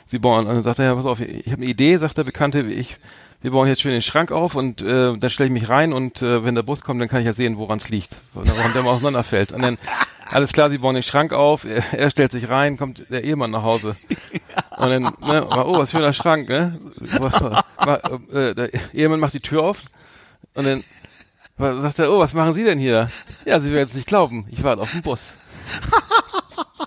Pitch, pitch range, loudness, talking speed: 130 Hz, 120-145 Hz, -19 LUFS, 240 wpm